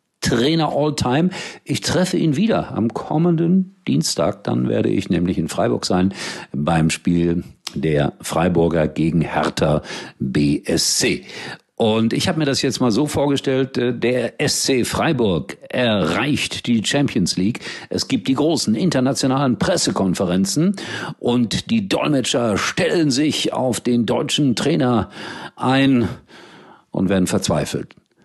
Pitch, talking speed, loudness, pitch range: 130 Hz, 125 wpm, -19 LUFS, 100-150 Hz